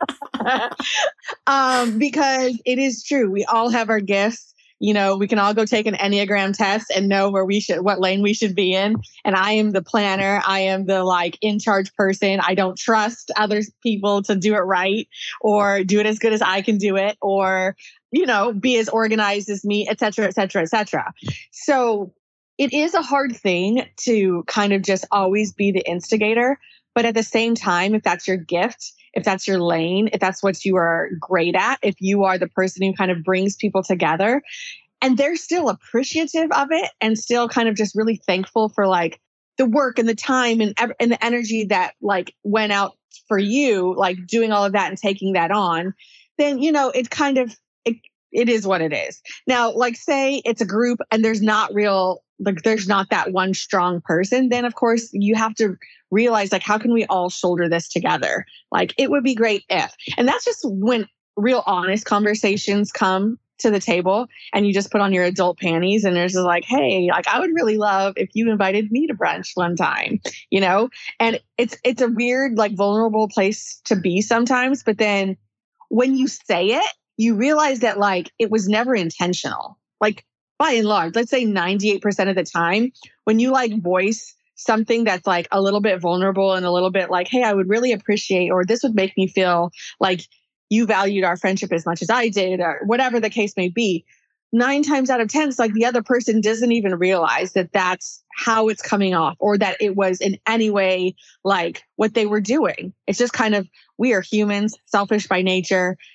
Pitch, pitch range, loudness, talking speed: 210 Hz, 190-230 Hz, -19 LUFS, 205 wpm